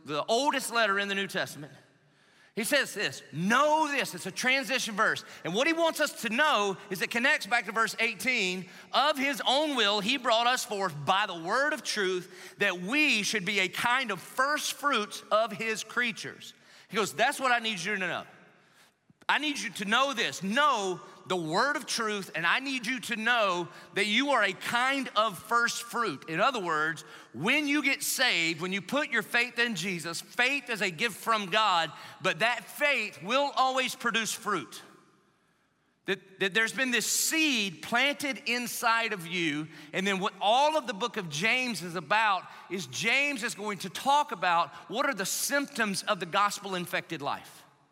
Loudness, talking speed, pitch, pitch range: -28 LUFS, 190 wpm, 225 Hz, 190-260 Hz